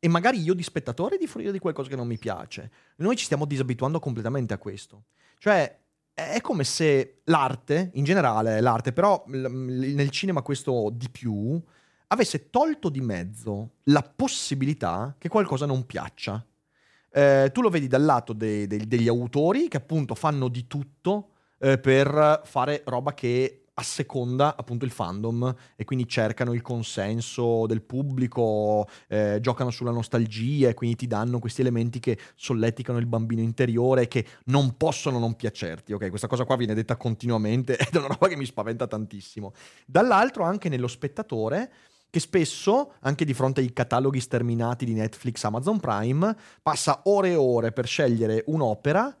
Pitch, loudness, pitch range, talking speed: 130 Hz, -25 LUFS, 115-150 Hz, 165 wpm